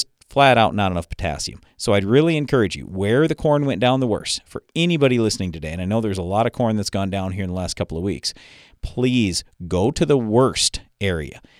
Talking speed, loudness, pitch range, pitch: 235 wpm, -20 LUFS, 90-125 Hz, 100 Hz